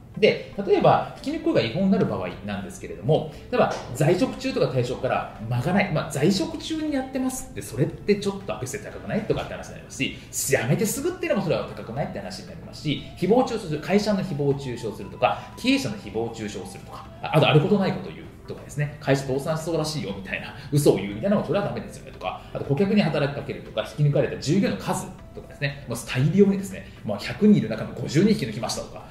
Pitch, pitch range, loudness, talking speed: 155 Hz, 130-210 Hz, -25 LUFS, 500 characters per minute